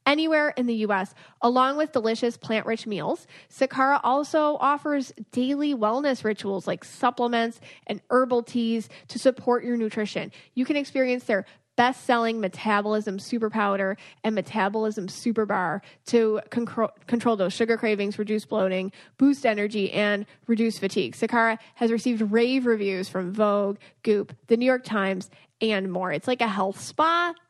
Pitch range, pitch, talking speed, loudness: 200-245 Hz, 225 Hz, 155 wpm, -25 LUFS